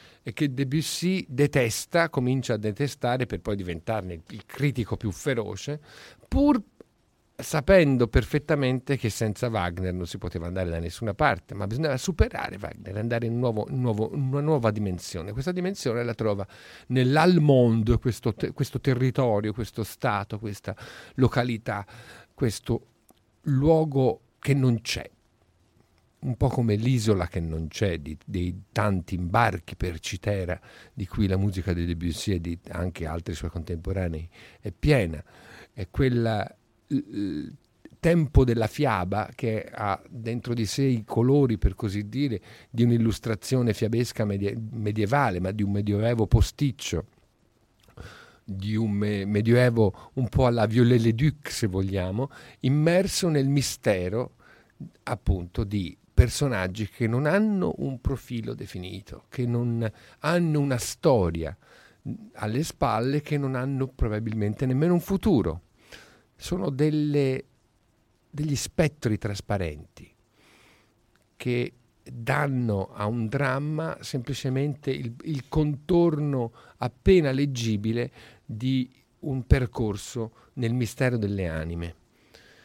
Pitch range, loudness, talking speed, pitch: 100-135 Hz, -26 LUFS, 125 wpm, 115 Hz